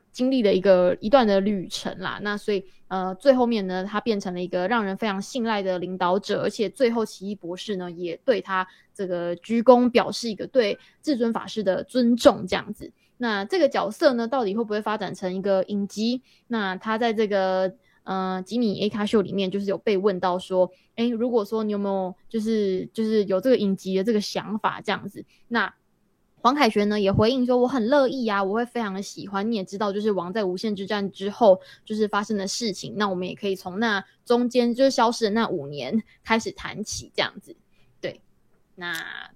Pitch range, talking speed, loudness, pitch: 190-230 Hz, 300 characters per minute, -24 LUFS, 205 Hz